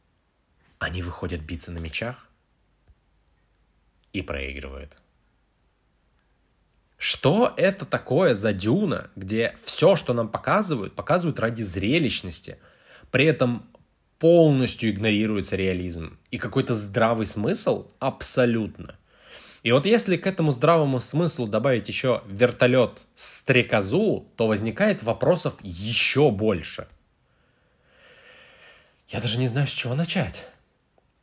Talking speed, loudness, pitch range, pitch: 100 wpm, -23 LUFS, 90-130 Hz, 110 Hz